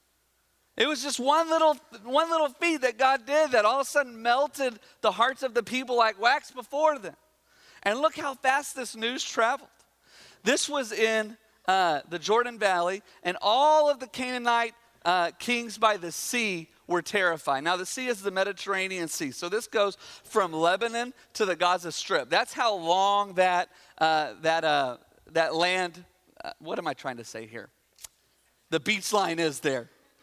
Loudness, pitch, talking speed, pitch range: -27 LUFS, 220 Hz, 180 wpm, 175-260 Hz